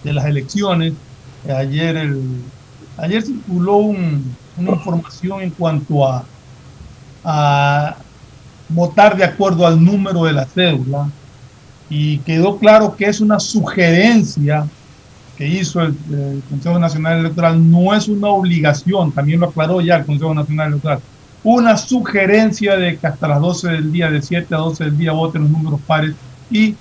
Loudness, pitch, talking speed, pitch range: -15 LUFS, 160 Hz, 155 wpm, 145-180 Hz